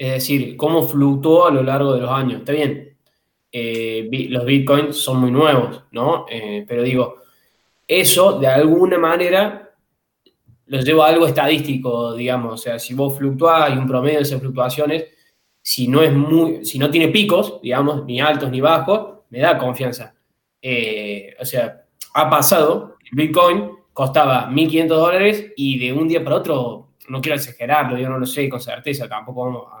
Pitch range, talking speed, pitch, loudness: 125-155 Hz, 175 wpm, 140 Hz, -17 LUFS